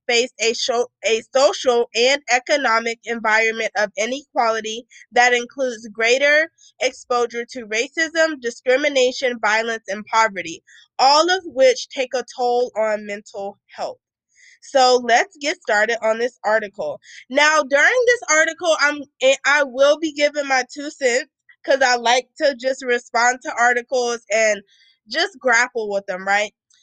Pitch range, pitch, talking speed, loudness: 225-290 Hz, 250 Hz, 140 wpm, -18 LUFS